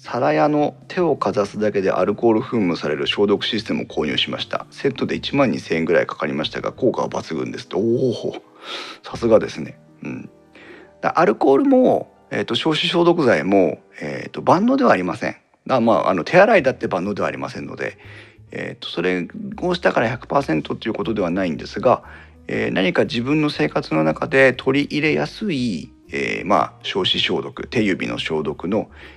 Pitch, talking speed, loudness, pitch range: 125 Hz, 370 characters per minute, -19 LUFS, 100-160 Hz